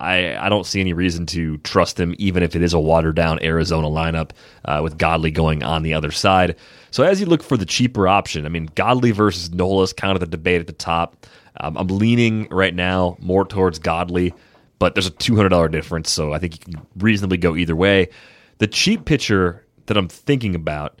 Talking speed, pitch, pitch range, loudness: 215 wpm, 90 Hz, 80-100 Hz, -19 LUFS